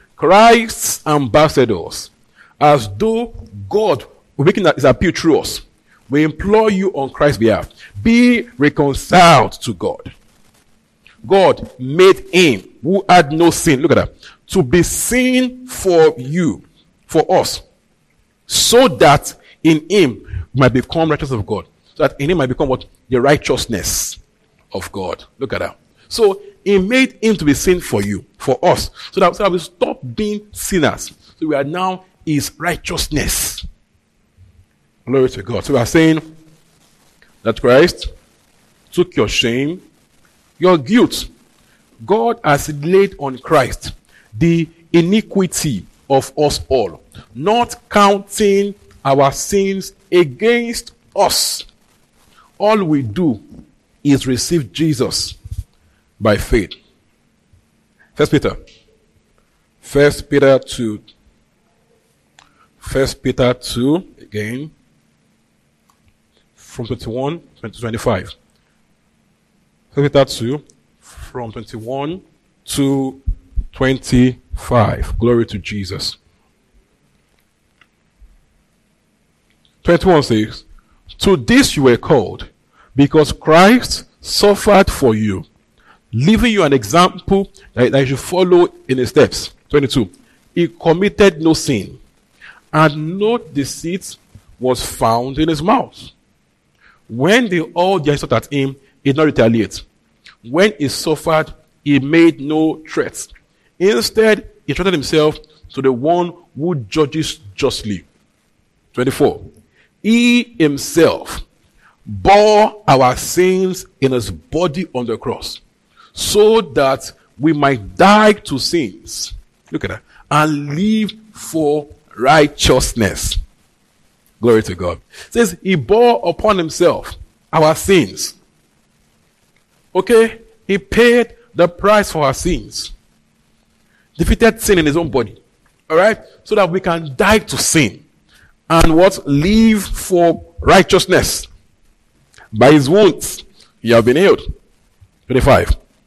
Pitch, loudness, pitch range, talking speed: 155 Hz, -14 LUFS, 125-190 Hz, 120 wpm